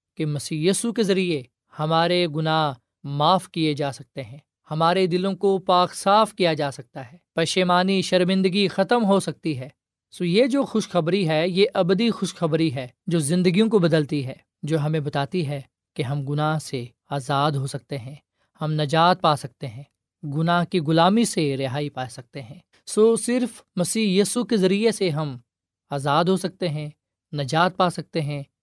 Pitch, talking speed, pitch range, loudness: 160 Hz, 170 wpm, 145-185 Hz, -22 LUFS